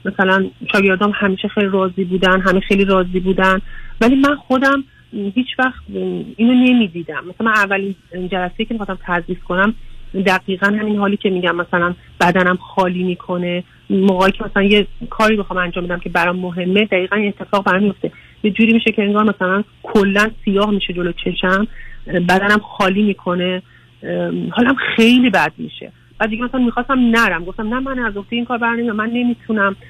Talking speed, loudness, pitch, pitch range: 160 wpm, -16 LUFS, 200 Hz, 185-225 Hz